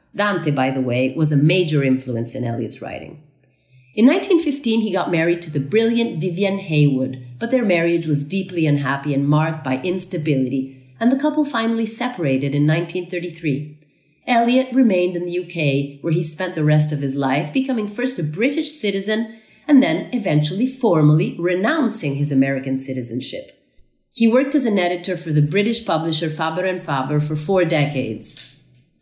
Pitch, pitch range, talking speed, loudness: 165 Hz, 140-215 Hz, 160 wpm, -18 LUFS